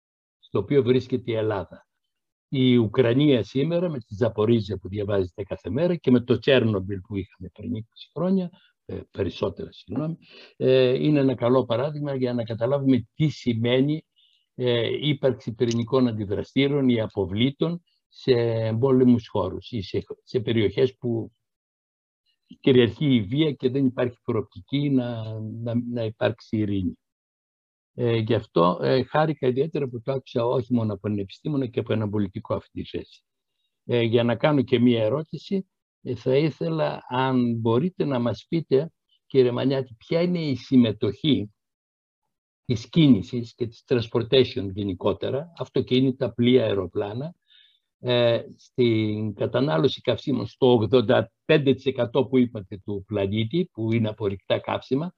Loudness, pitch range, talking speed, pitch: -24 LUFS, 110-135 Hz, 140 wpm, 125 Hz